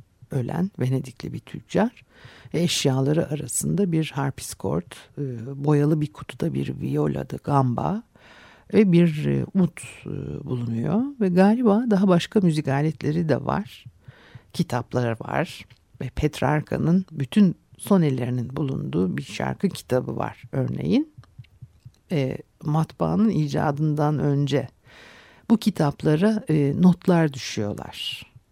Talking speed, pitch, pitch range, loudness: 100 wpm, 145 Hz, 125-165 Hz, -23 LUFS